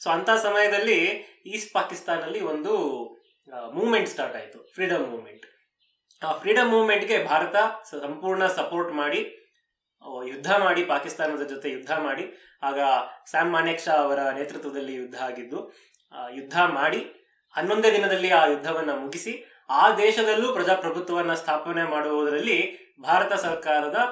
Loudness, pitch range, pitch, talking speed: -24 LUFS, 145-215 Hz, 170 Hz, 115 wpm